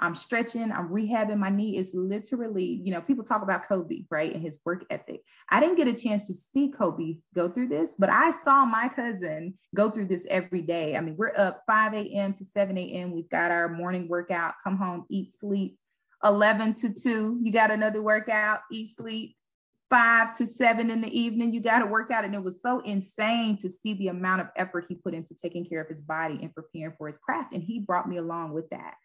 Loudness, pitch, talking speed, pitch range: -27 LUFS, 200 Hz, 225 wpm, 175-225 Hz